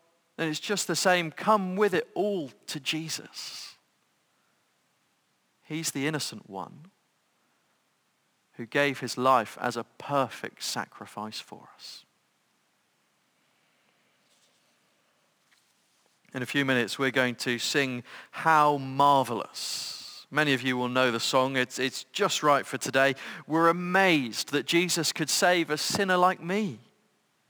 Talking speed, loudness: 125 wpm, -27 LUFS